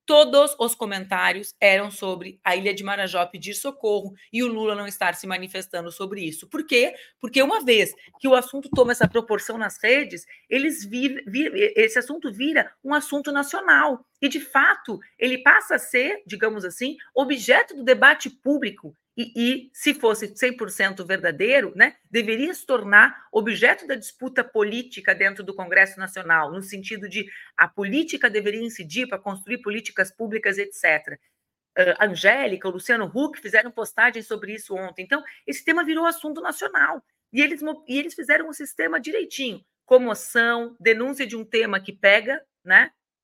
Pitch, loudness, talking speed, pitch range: 235 Hz, -21 LUFS, 160 wpm, 200-280 Hz